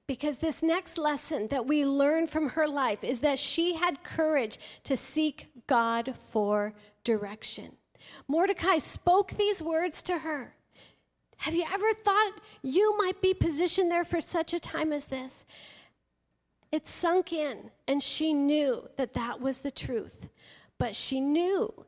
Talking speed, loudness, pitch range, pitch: 150 wpm, -28 LUFS, 270-350 Hz, 310 Hz